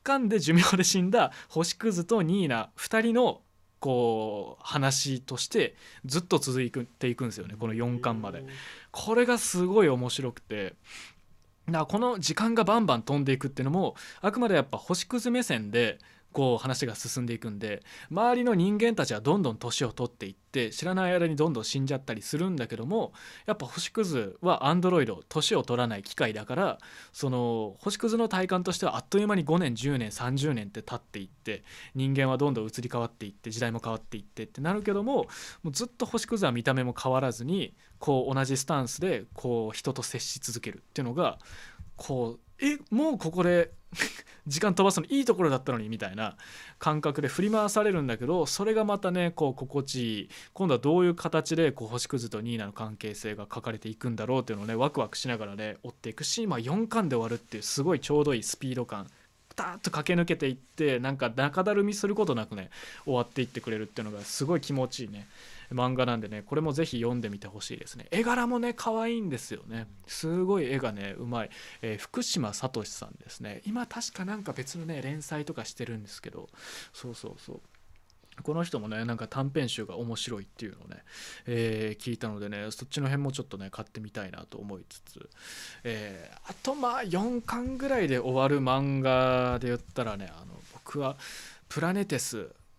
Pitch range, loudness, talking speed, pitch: 115-180 Hz, -30 LUFS, 395 characters per minute, 135 Hz